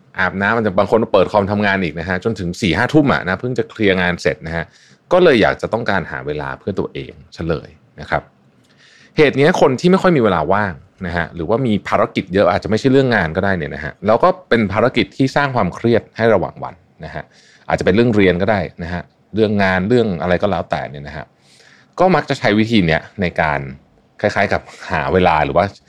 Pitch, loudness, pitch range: 95 Hz, -16 LUFS, 85-115 Hz